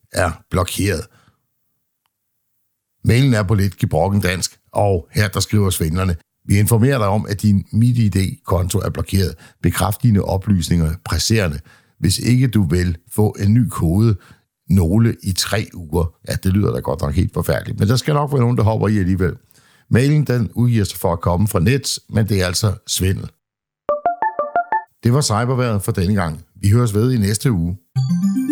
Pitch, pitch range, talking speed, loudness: 105 Hz, 95-120 Hz, 175 wpm, -18 LUFS